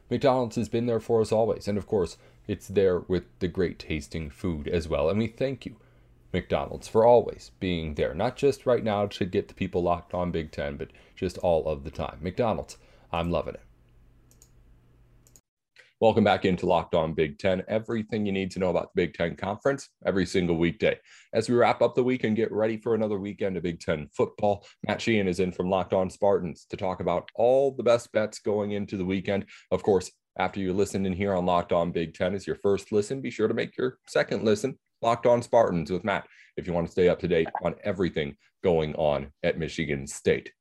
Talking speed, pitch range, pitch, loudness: 220 wpm, 85-110 Hz, 100 Hz, -27 LUFS